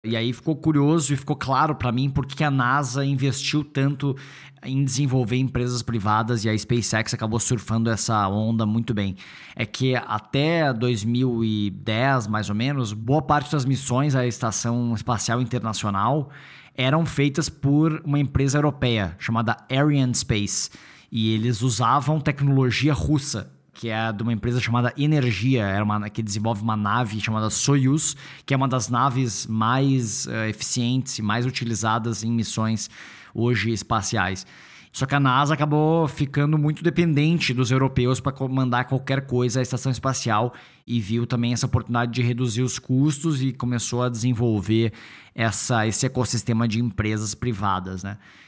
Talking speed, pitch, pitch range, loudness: 145 wpm, 125 Hz, 115-140 Hz, -23 LUFS